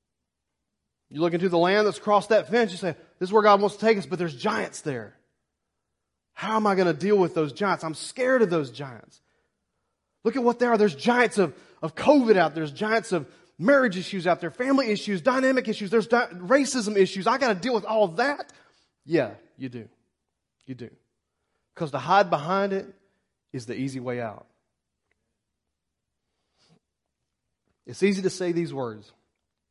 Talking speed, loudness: 190 wpm, -24 LUFS